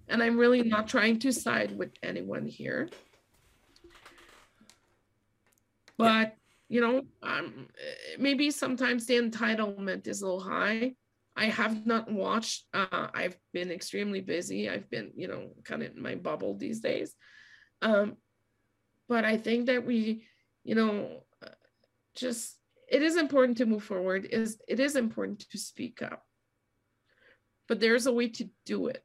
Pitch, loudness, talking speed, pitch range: 225 Hz, -30 LUFS, 150 wpm, 205-250 Hz